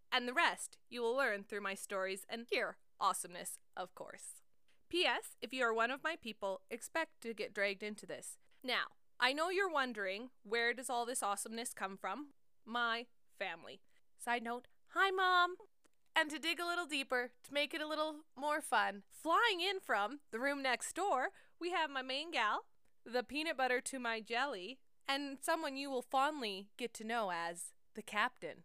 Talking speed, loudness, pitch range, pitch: 185 wpm, -38 LUFS, 230-305 Hz, 250 Hz